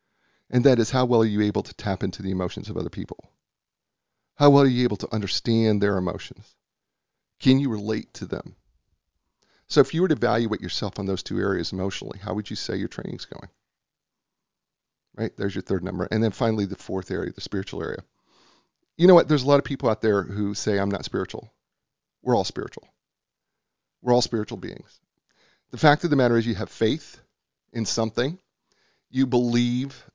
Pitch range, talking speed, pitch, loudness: 100-125 Hz, 195 wpm, 110 Hz, -24 LUFS